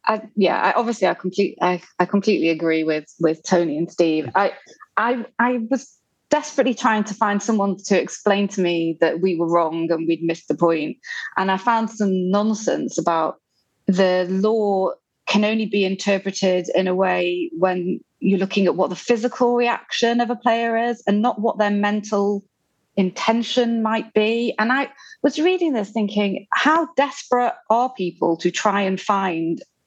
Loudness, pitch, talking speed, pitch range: -20 LUFS, 205 Hz, 175 wpm, 185-235 Hz